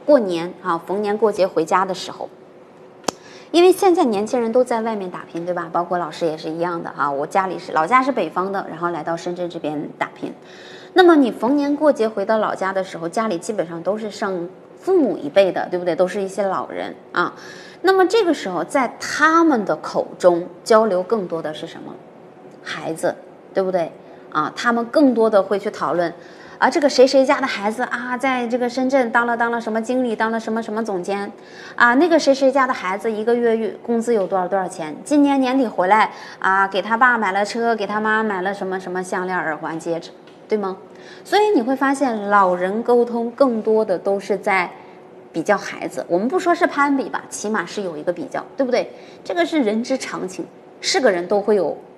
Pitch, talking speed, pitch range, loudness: 215 Hz, 300 characters per minute, 180-255 Hz, -19 LUFS